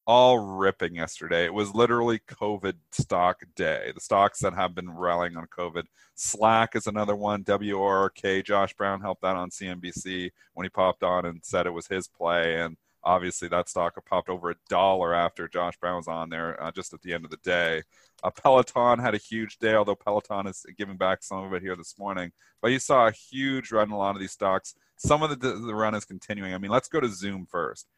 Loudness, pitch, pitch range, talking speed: -27 LUFS, 95 Hz, 90-105 Hz, 220 wpm